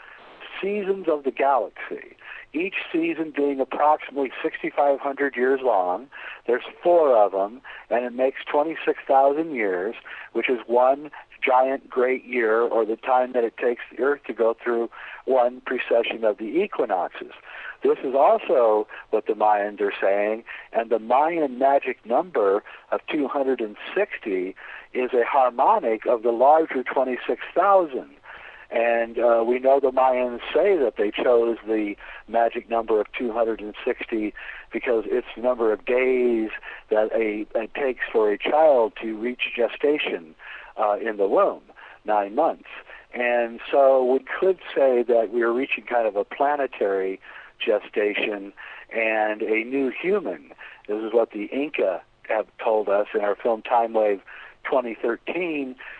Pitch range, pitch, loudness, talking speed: 110-145 Hz, 125 Hz, -23 LUFS, 145 wpm